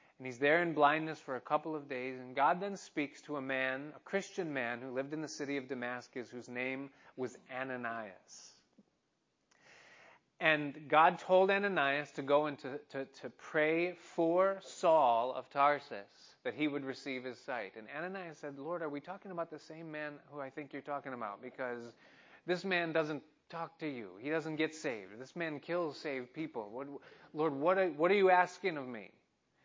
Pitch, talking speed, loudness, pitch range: 145 Hz, 190 wpm, -35 LUFS, 130-165 Hz